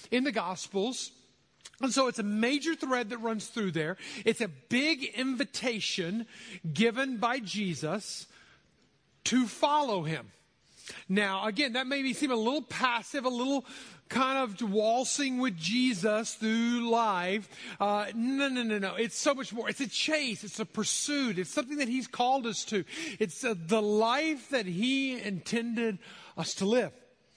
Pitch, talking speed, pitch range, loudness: 230 Hz, 160 wpm, 210-260 Hz, -31 LUFS